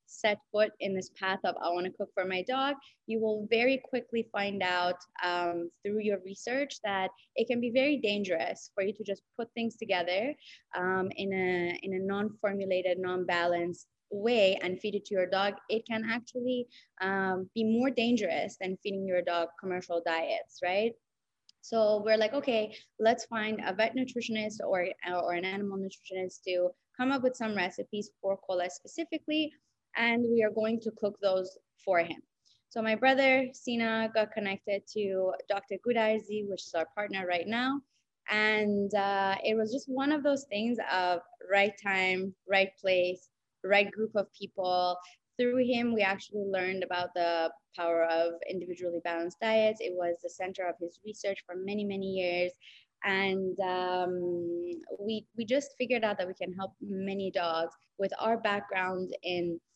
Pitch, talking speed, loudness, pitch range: 200 Hz, 170 wpm, -31 LUFS, 180-220 Hz